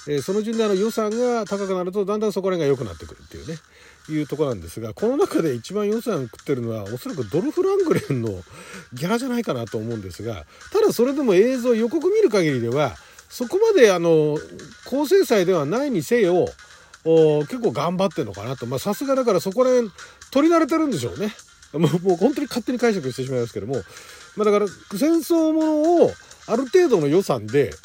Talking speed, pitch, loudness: 415 characters per minute, 200 Hz, -21 LUFS